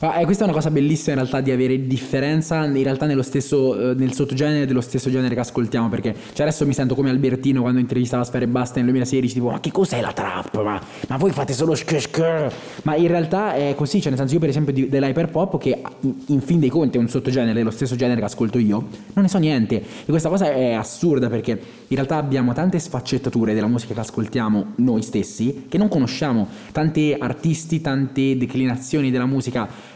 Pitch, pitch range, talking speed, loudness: 135 Hz, 125-155 Hz, 205 wpm, -20 LUFS